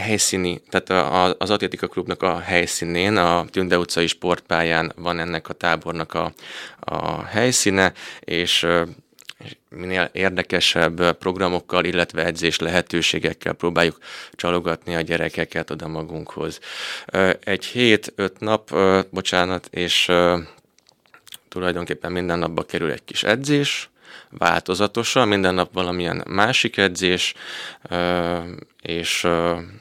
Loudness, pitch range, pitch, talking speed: -21 LUFS, 85-95 Hz, 90 Hz, 105 wpm